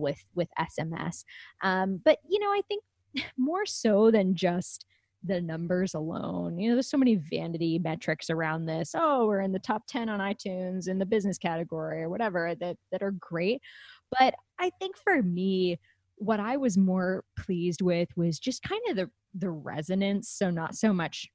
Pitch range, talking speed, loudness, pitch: 165-225 Hz, 185 wpm, -29 LUFS, 185 Hz